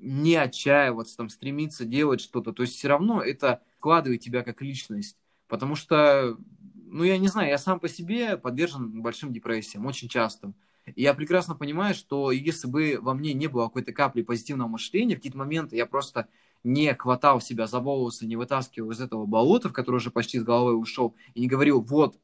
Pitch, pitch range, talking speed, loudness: 130 Hz, 120-150 Hz, 190 wpm, -26 LUFS